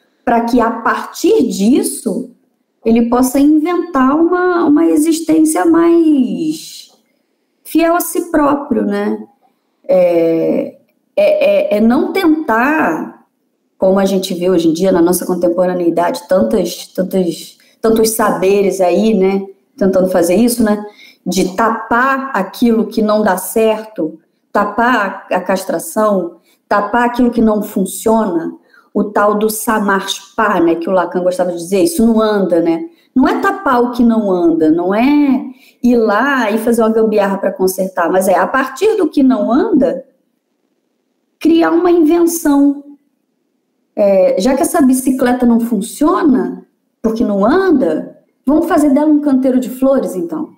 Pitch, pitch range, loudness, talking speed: 240 Hz, 200-290 Hz, -13 LUFS, 140 wpm